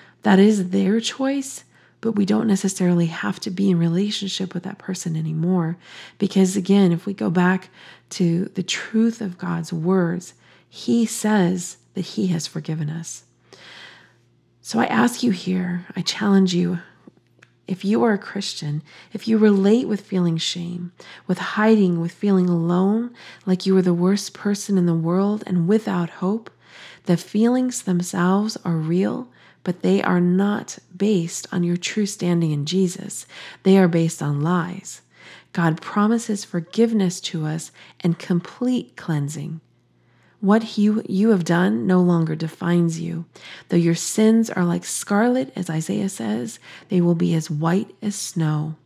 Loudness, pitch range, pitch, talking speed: -21 LUFS, 170-205 Hz, 185 Hz, 155 wpm